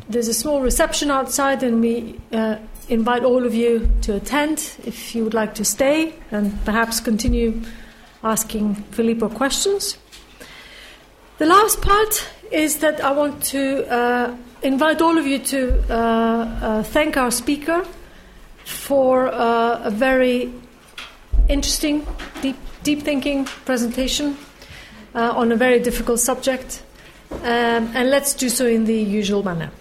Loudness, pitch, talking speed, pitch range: -19 LUFS, 245 Hz, 135 wpm, 230-280 Hz